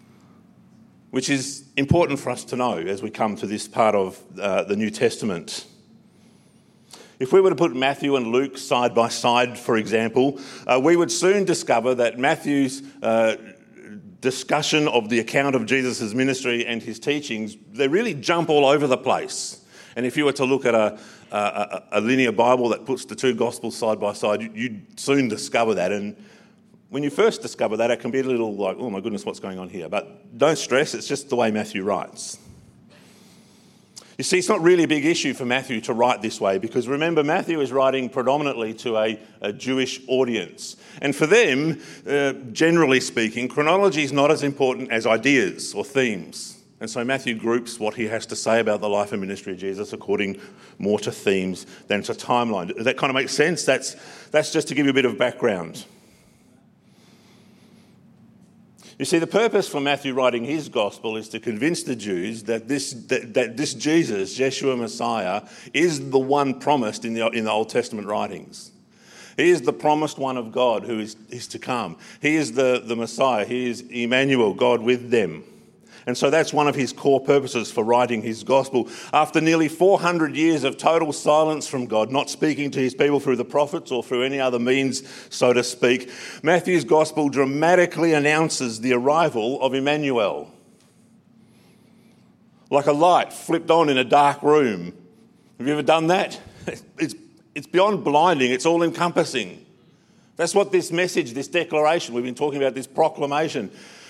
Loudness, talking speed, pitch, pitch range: -22 LUFS, 185 wpm, 135 Hz, 120-155 Hz